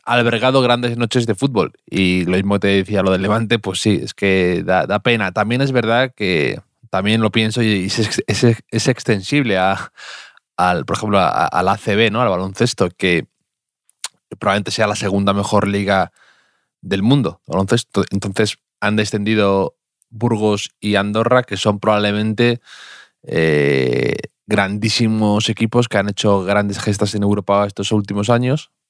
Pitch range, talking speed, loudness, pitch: 100-115 Hz, 145 wpm, -17 LUFS, 105 Hz